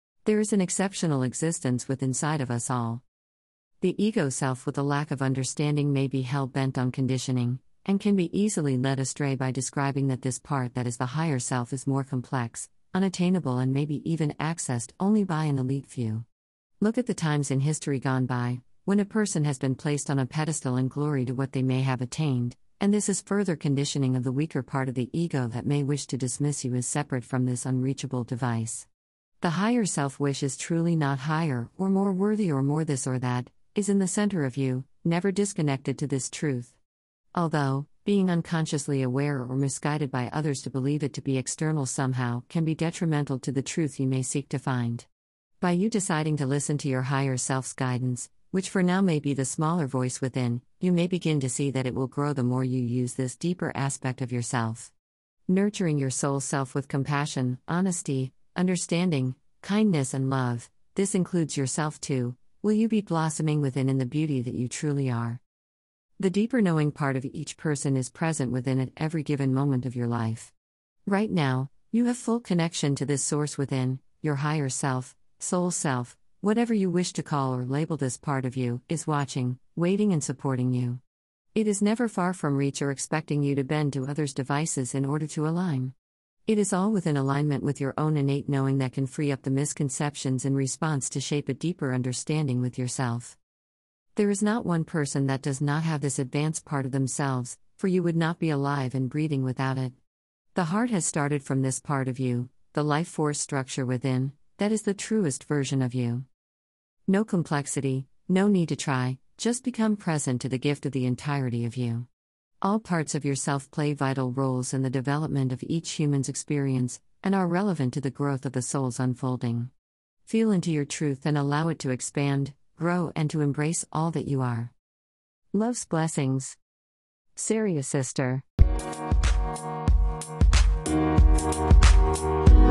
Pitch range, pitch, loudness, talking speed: 130-160 Hz, 140 Hz, -27 LUFS, 190 wpm